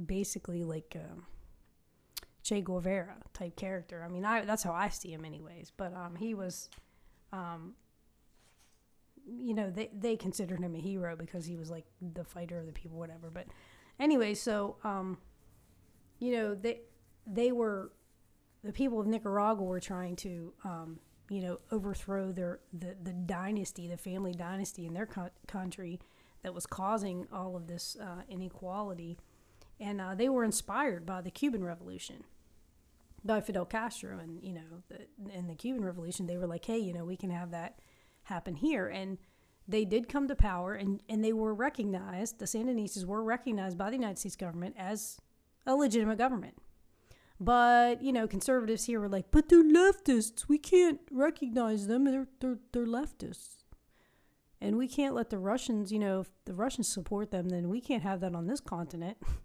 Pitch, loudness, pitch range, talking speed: 195 Hz, -34 LUFS, 175-225 Hz, 175 wpm